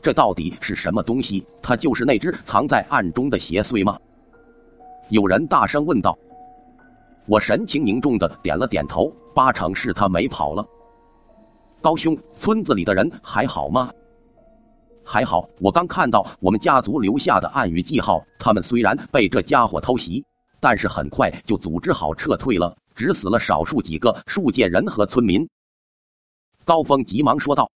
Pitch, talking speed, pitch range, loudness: 235 Hz, 240 characters per minute, 160-245 Hz, -20 LUFS